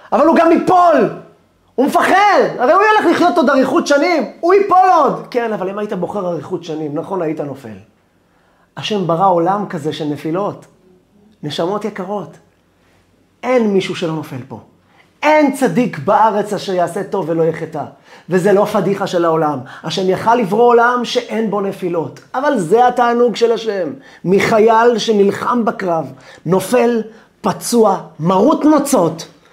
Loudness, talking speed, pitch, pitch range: -14 LUFS, 145 wpm, 200 Hz, 165-240 Hz